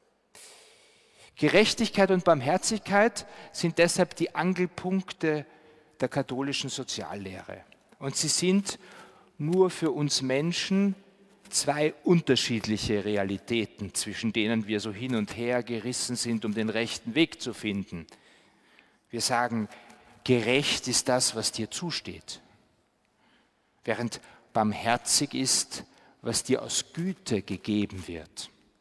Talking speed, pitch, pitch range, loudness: 110 wpm, 130 Hz, 110-170 Hz, -27 LUFS